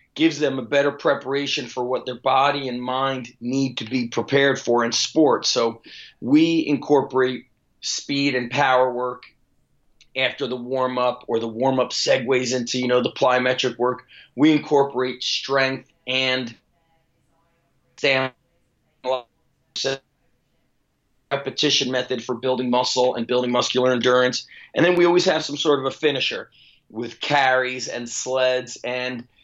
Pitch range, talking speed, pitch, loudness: 125-140 Hz, 140 wpm, 130 Hz, -21 LUFS